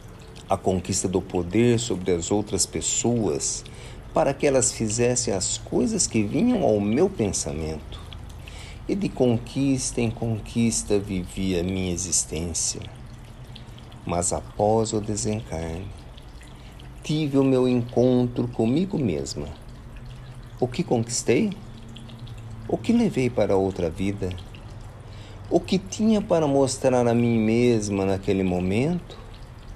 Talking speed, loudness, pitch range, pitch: 115 wpm, -24 LUFS, 100-125 Hz, 115 Hz